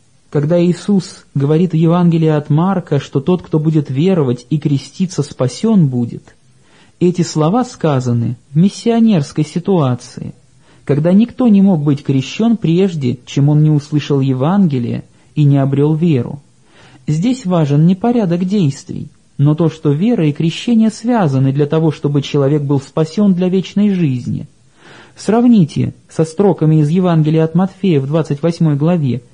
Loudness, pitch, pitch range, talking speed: -14 LUFS, 155 Hz, 145-185 Hz, 140 wpm